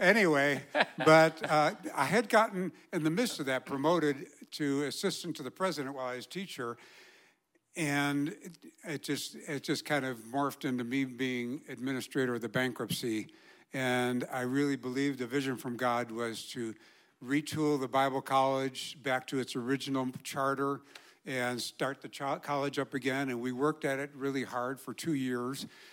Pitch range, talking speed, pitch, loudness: 130-150 Hz, 165 wpm, 140 Hz, -33 LUFS